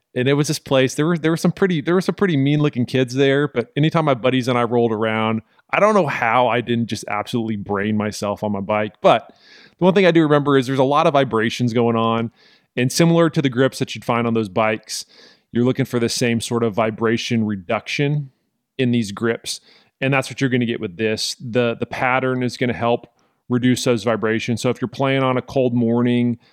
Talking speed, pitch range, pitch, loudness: 235 wpm, 115-135 Hz, 125 Hz, -19 LUFS